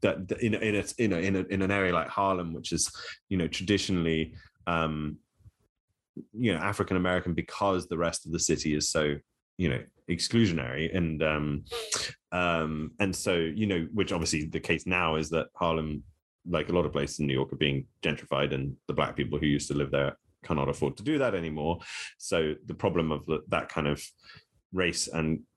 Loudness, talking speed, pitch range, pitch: -30 LUFS, 195 wpm, 75-95 Hz, 80 Hz